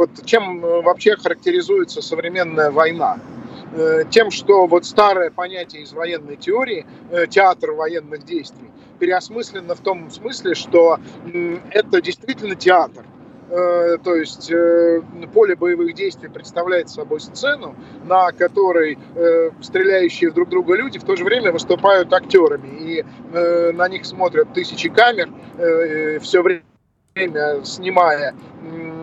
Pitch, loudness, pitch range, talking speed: 180 Hz, -17 LUFS, 165-240 Hz, 110 wpm